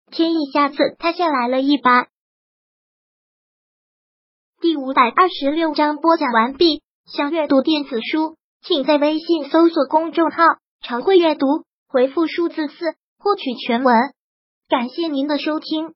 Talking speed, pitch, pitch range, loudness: 205 characters per minute, 310 Hz, 280-330 Hz, -18 LUFS